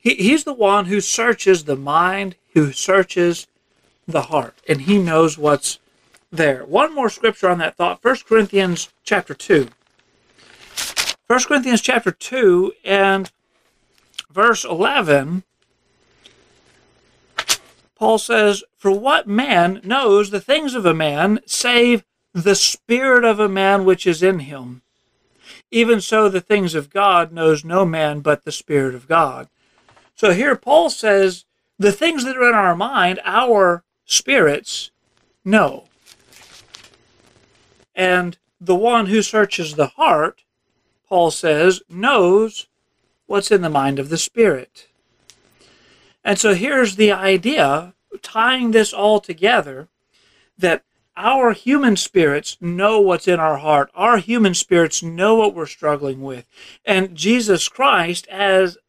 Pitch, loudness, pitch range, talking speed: 195 Hz, -16 LUFS, 170-225 Hz, 130 wpm